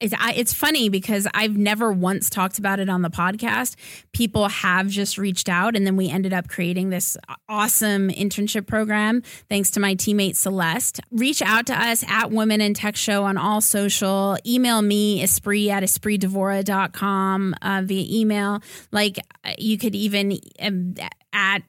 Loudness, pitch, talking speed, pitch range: -21 LUFS, 205 Hz, 160 wpm, 190-215 Hz